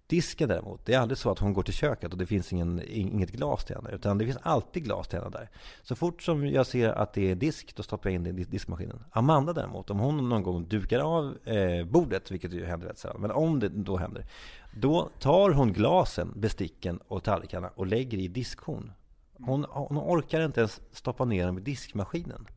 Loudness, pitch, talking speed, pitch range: -30 LUFS, 110 Hz, 220 wpm, 95-135 Hz